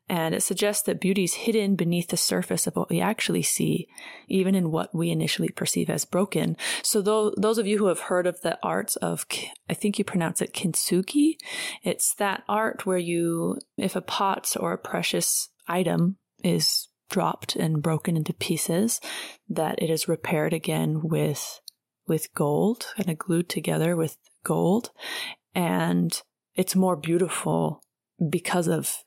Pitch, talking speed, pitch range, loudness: 180 Hz, 165 wpm, 165-200 Hz, -26 LUFS